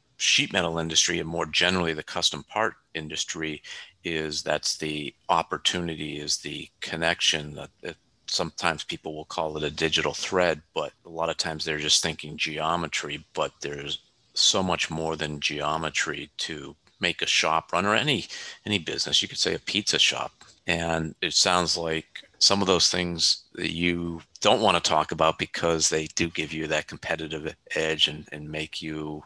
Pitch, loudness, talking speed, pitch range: 80 Hz, -25 LUFS, 175 wpm, 75-85 Hz